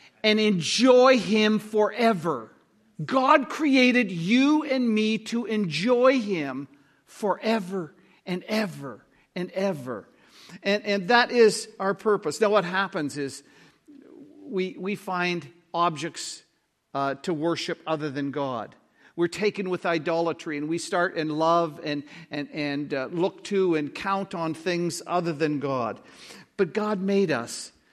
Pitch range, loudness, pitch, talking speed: 160-215 Hz, -25 LUFS, 185 Hz, 135 wpm